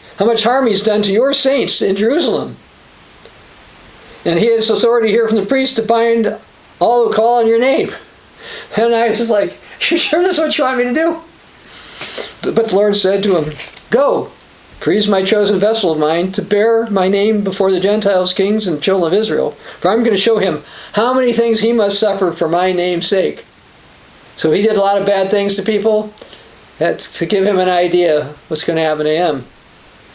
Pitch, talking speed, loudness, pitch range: 210 Hz, 210 wpm, -14 LUFS, 190-230 Hz